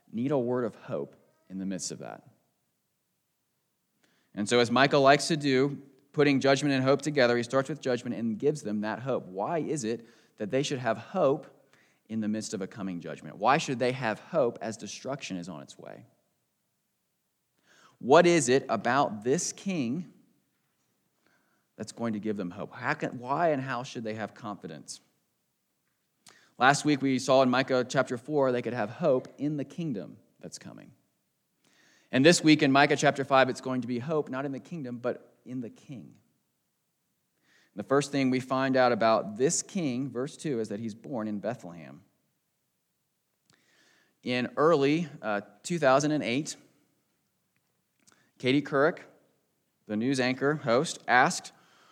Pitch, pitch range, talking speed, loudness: 130 Hz, 115-140 Hz, 165 wpm, -28 LUFS